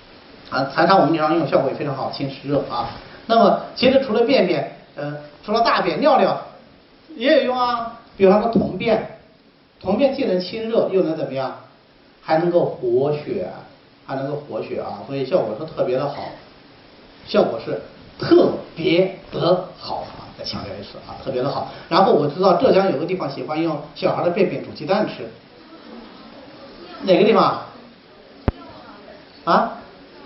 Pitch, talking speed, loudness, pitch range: 185 Hz, 235 characters per minute, -20 LUFS, 150-230 Hz